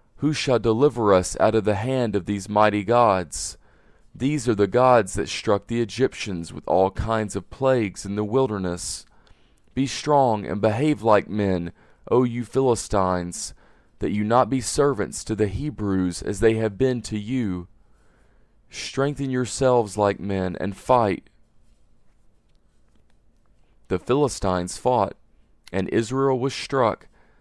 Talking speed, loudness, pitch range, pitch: 140 wpm, -23 LUFS, 100-125 Hz, 110 Hz